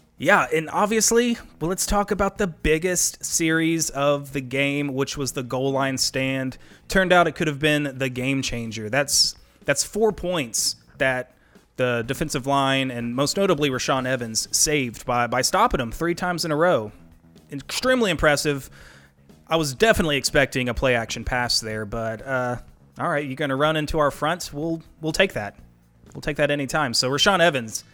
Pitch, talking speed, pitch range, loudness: 140 Hz, 175 wpm, 125-160 Hz, -22 LUFS